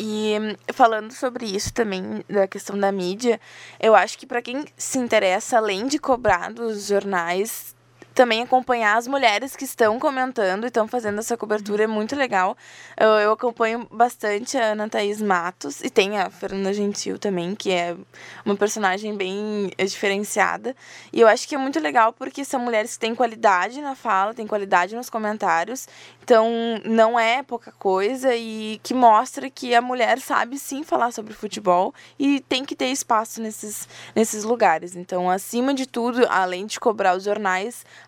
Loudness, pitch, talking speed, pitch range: -22 LUFS, 215 Hz, 170 wpm, 195-245 Hz